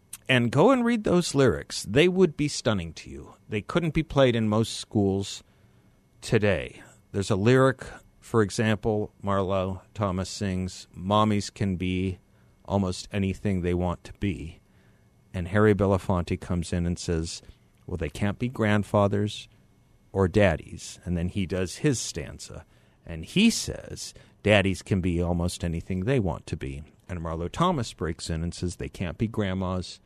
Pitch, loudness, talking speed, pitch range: 100 Hz, -26 LUFS, 160 wpm, 90-110 Hz